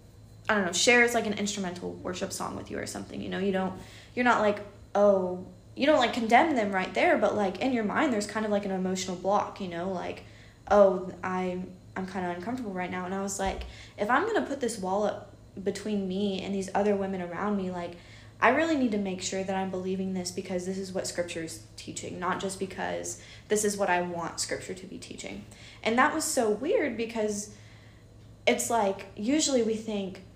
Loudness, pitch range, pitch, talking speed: -28 LUFS, 175-210 Hz, 195 Hz, 225 wpm